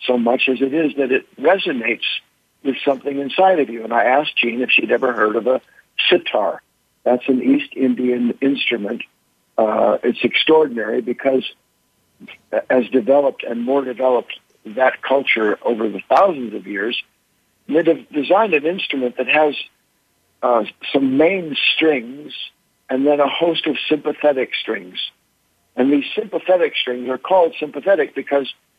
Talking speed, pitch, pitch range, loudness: 145 wpm, 140 Hz, 125-150 Hz, -18 LUFS